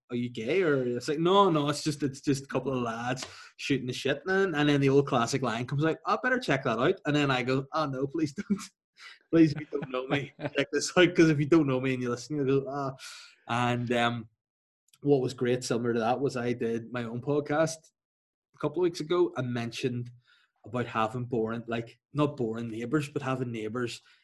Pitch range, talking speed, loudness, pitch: 120-150 Hz, 230 wpm, -29 LUFS, 135 Hz